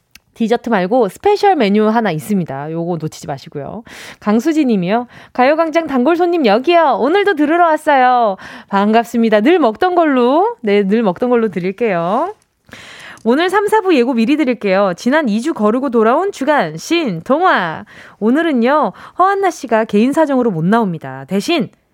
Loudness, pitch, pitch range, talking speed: -14 LUFS, 240 Hz, 210-320 Hz, 325 characters per minute